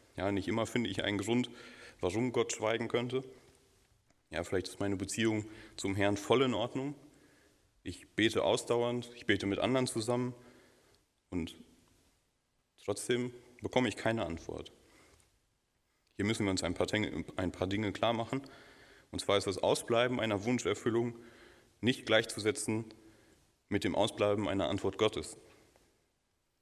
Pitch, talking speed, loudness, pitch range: 115 Hz, 135 wpm, -34 LUFS, 100-120 Hz